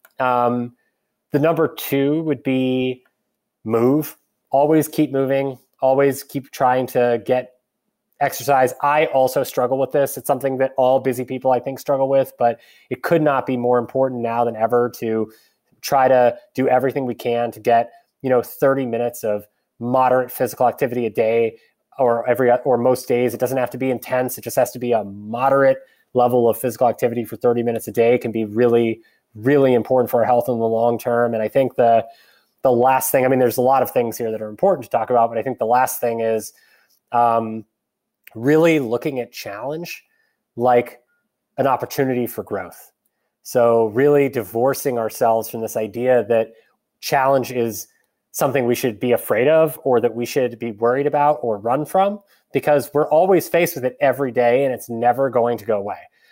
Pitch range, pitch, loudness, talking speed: 120-135 Hz, 125 Hz, -19 LUFS, 190 wpm